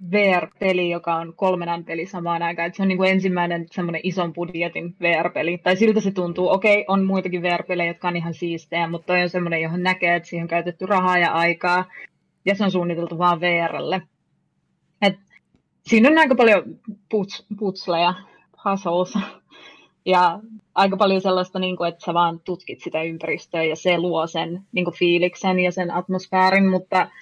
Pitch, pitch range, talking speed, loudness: 180 Hz, 170-190 Hz, 175 wpm, -21 LUFS